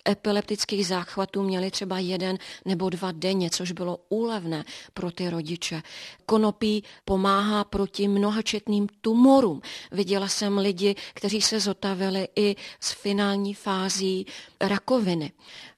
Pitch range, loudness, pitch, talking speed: 185-205 Hz, -26 LUFS, 195 Hz, 115 wpm